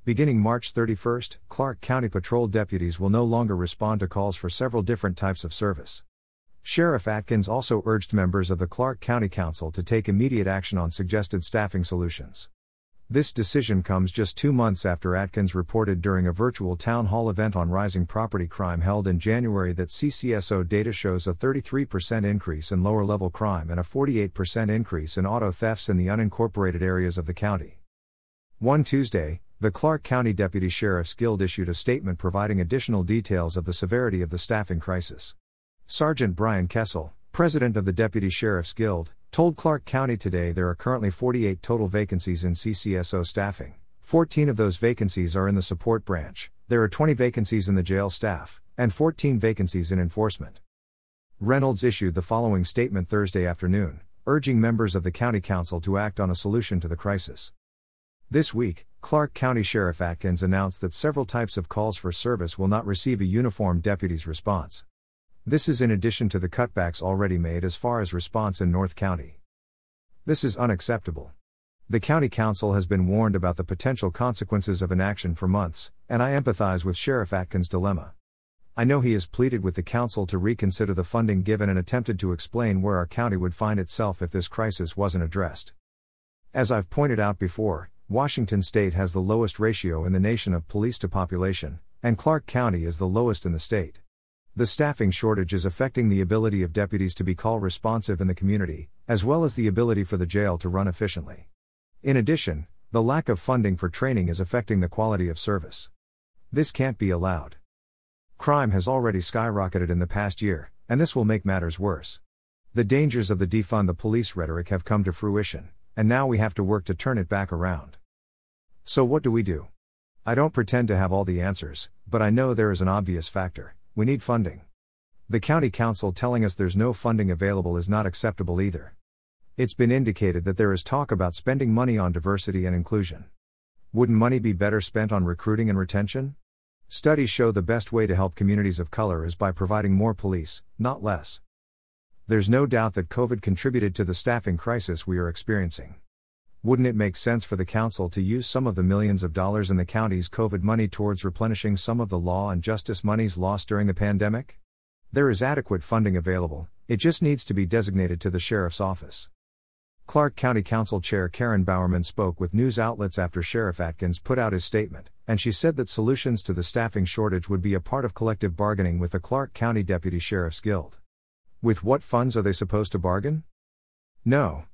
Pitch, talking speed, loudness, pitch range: 100 Hz, 190 wpm, -25 LUFS, 90-115 Hz